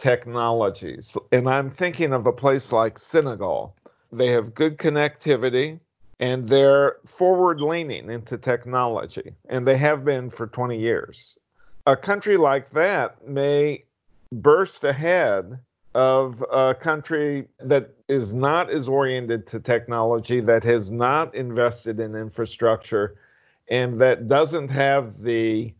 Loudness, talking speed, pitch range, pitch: -22 LUFS, 125 wpm, 115-140 Hz, 130 Hz